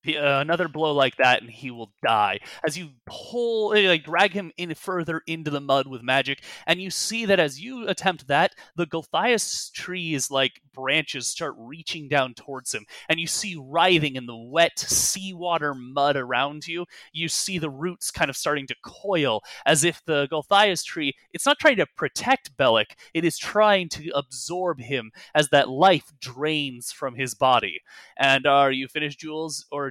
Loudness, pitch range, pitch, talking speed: -23 LUFS, 135-175 Hz, 155 Hz, 180 wpm